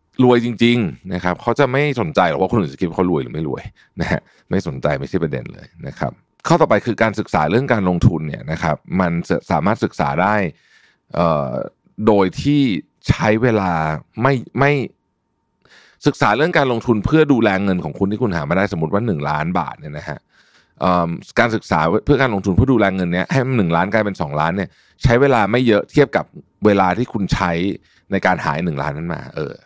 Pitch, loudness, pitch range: 105 Hz, -18 LUFS, 90-125 Hz